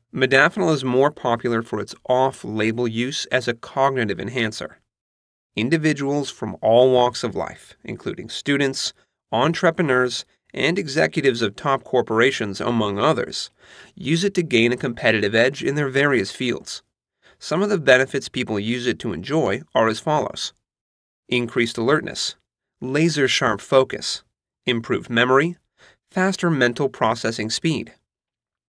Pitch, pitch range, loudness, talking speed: 125 Hz, 115-145 Hz, -21 LUFS, 125 wpm